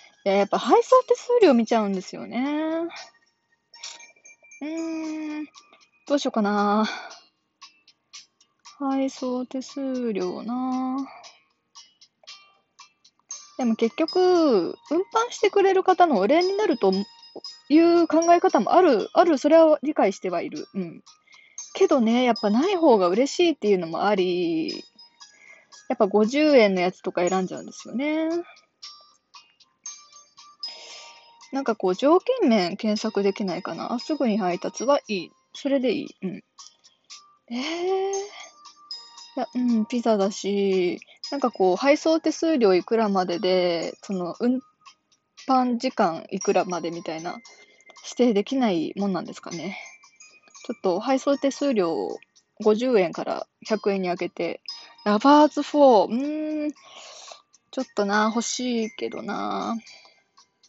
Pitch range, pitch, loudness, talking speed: 210-325 Hz, 260 Hz, -23 LUFS, 235 characters per minute